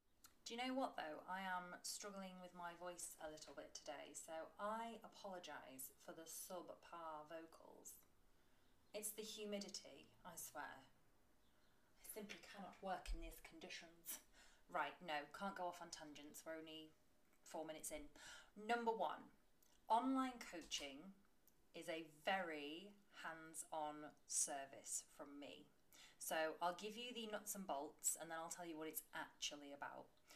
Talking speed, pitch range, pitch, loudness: 150 wpm, 155-205 Hz, 175 Hz, -50 LUFS